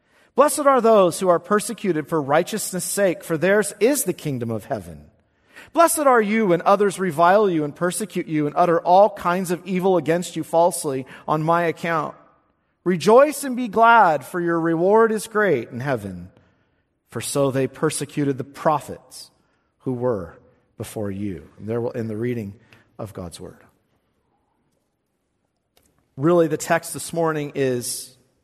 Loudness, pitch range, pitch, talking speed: -20 LUFS, 125-190 Hz, 165 Hz, 155 wpm